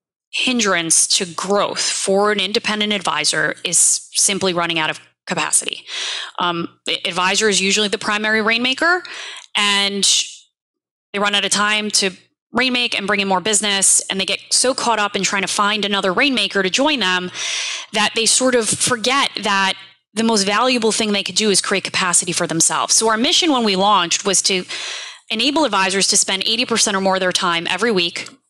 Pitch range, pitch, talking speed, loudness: 190-225 Hz, 205 Hz, 185 wpm, -16 LUFS